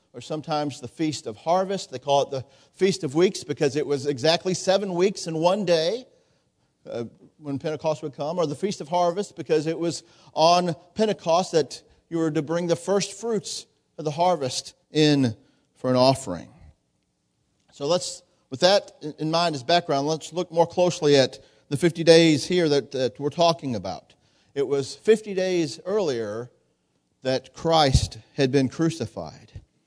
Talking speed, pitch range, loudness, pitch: 165 wpm, 140-175 Hz, -24 LUFS, 160 Hz